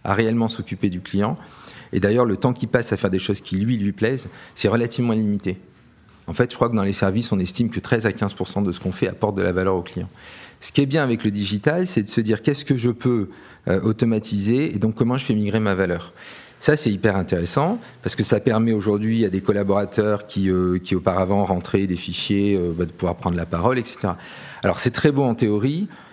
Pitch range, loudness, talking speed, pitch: 95-120 Hz, -21 LUFS, 235 wpm, 105 Hz